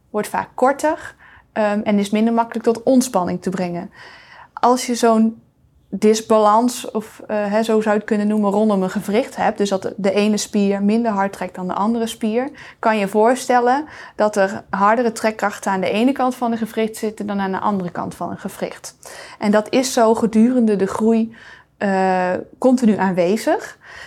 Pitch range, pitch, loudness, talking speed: 200-235 Hz, 220 Hz, -18 LUFS, 185 wpm